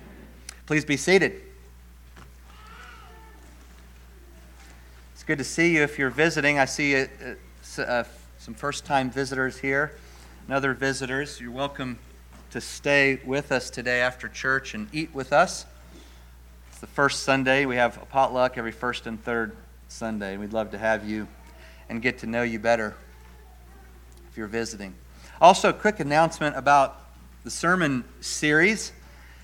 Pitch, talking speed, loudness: 115 Hz, 145 wpm, -24 LUFS